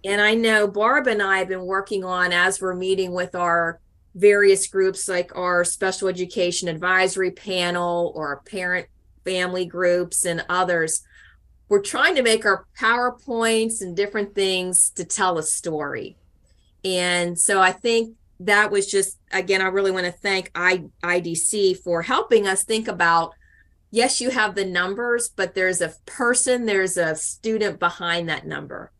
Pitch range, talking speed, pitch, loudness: 175-205 Hz, 160 wpm, 190 Hz, -21 LUFS